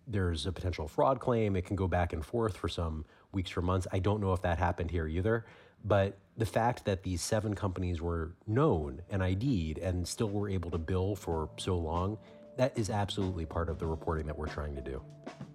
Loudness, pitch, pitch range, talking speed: -33 LUFS, 95 Hz, 85-105 Hz, 215 wpm